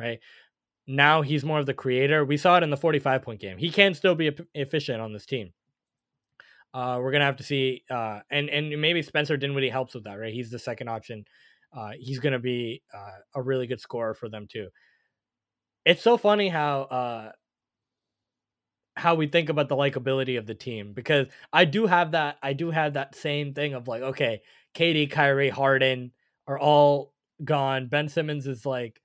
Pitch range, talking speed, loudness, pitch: 125-150 Hz, 190 wpm, -25 LUFS, 135 Hz